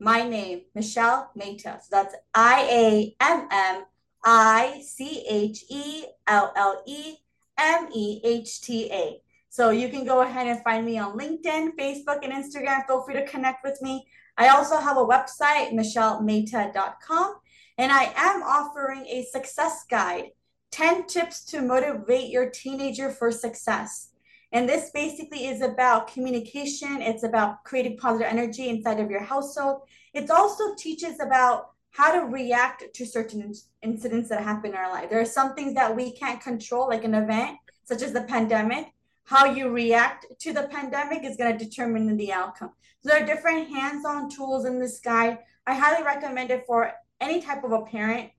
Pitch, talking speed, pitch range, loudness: 255 Hz, 175 wpm, 230-285 Hz, -24 LUFS